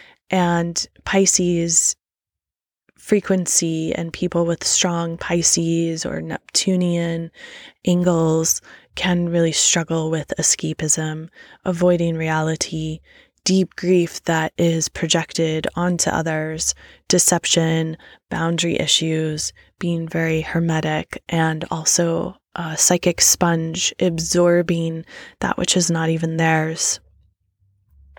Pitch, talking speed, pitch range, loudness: 165 Hz, 90 wpm, 160-175 Hz, -19 LUFS